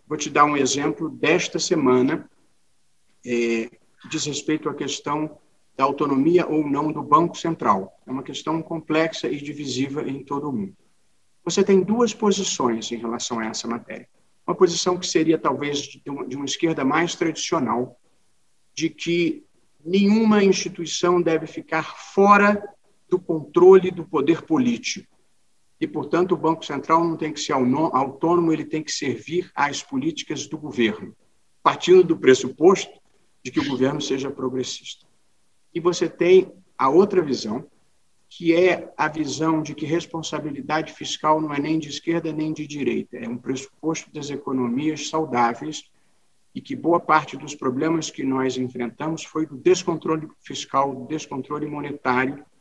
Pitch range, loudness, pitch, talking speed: 140-175 Hz, -22 LUFS, 155 Hz, 150 wpm